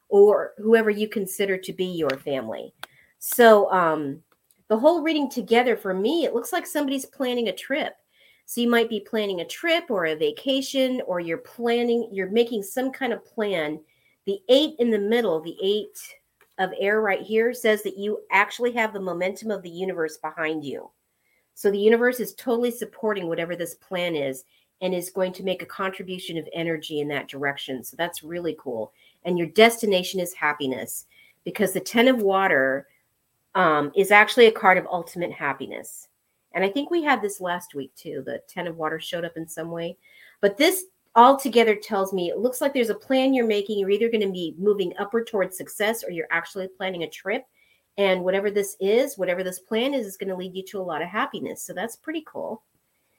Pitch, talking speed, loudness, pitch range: 195 Hz, 200 wpm, -23 LUFS, 175-230 Hz